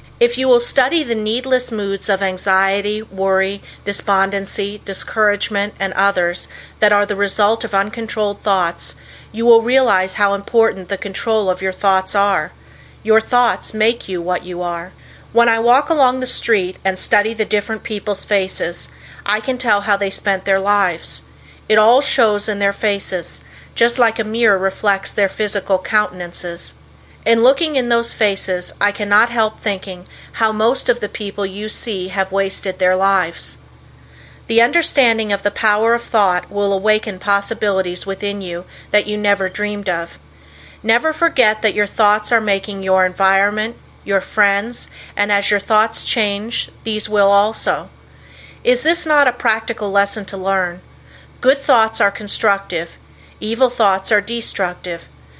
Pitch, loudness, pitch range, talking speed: 205 Hz, -17 LUFS, 195-225 Hz, 155 wpm